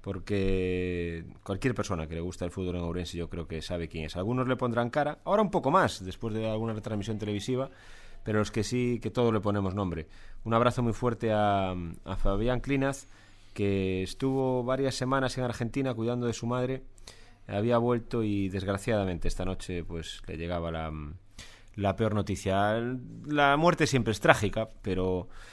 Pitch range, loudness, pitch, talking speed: 95-125 Hz, -30 LUFS, 105 Hz, 180 wpm